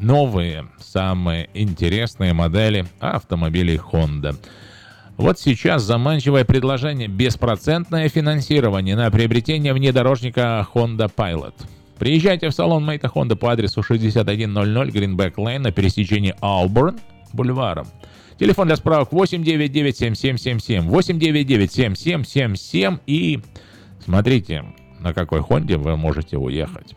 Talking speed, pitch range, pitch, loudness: 110 wpm, 95-140 Hz, 115 Hz, -19 LUFS